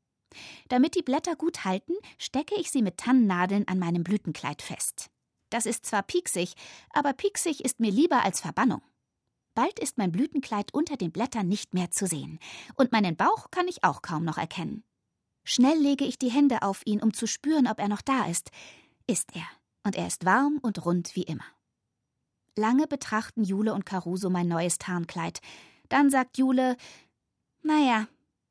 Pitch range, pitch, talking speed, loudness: 180-275 Hz, 220 Hz, 175 wpm, -27 LUFS